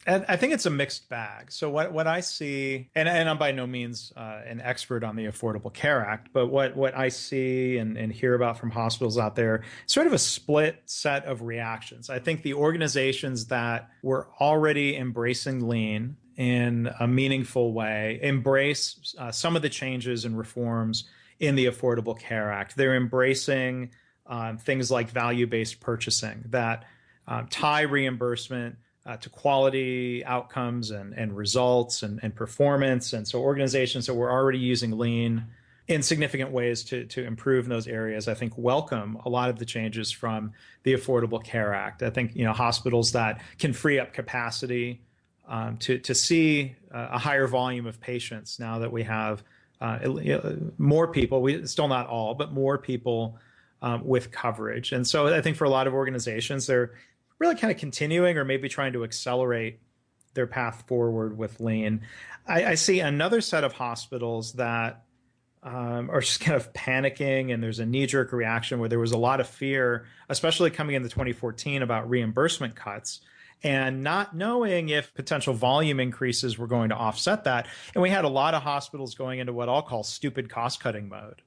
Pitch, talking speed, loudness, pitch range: 125 Hz, 180 wpm, -27 LUFS, 115-135 Hz